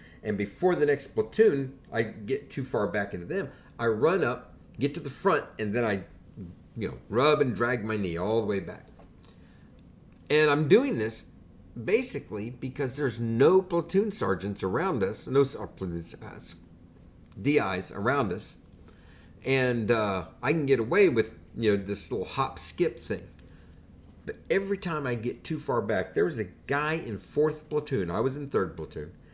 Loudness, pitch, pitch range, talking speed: -28 LUFS, 120 Hz, 90-145 Hz, 170 wpm